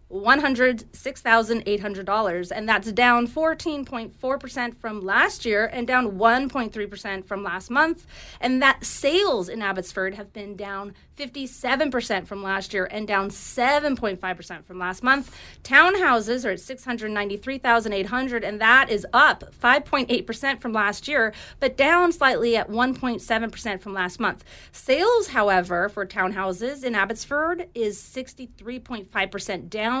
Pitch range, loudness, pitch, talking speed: 200-260 Hz, -22 LUFS, 230 Hz, 190 wpm